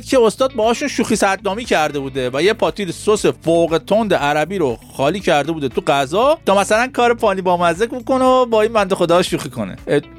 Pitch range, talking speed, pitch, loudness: 170-235 Hz, 195 wpm, 200 Hz, -16 LUFS